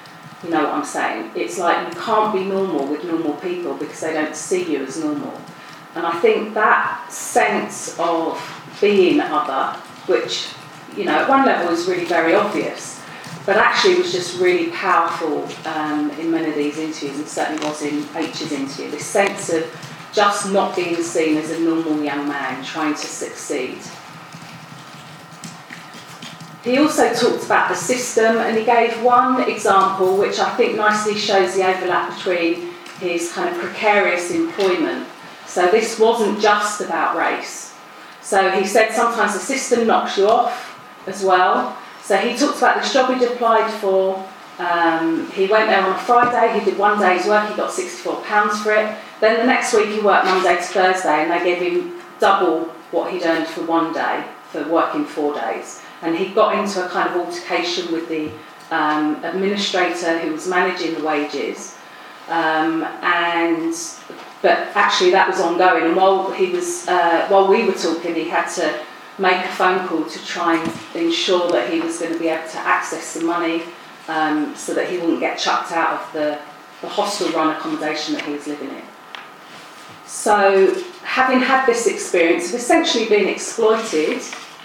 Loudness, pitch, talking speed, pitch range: -18 LUFS, 185 Hz, 175 wpm, 165-220 Hz